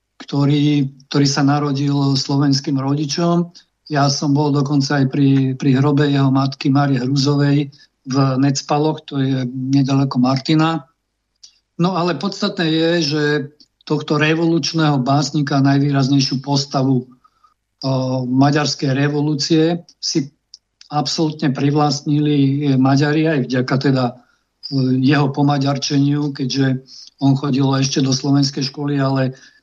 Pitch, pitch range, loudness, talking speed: 140 Hz, 135-150 Hz, -17 LUFS, 110 wpm